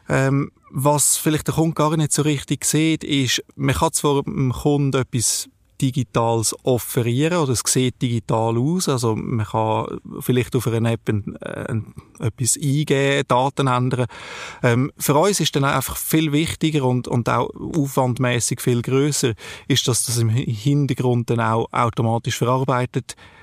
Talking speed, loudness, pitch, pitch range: 155 wpm, -20 LUFS, 130 Hz, 120-145 Hz